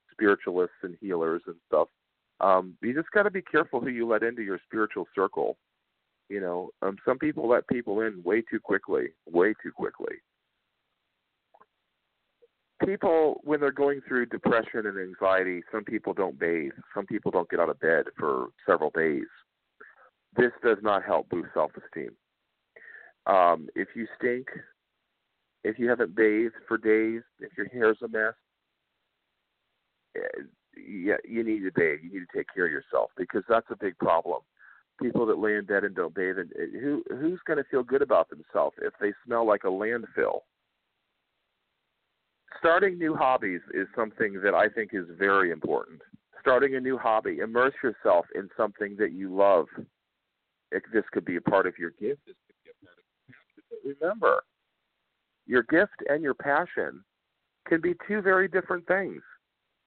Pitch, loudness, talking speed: 125 Hz, -27 LUFS, 160 wpm